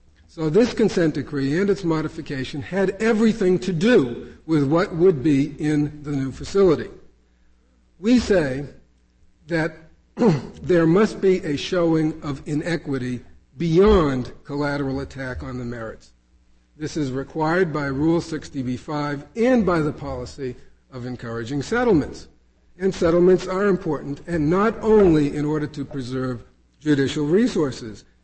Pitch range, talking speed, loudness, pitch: 130-180 Hz, 130 wpm, -21 LUFS, 150 Hz